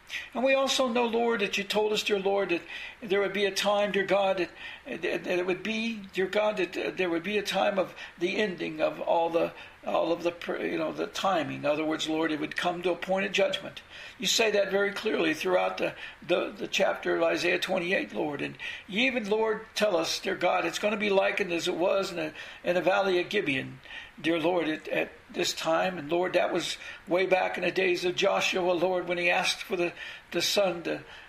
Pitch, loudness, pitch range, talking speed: 190 Hz, -28 LUFS, 175-210 Hz, 230 wpm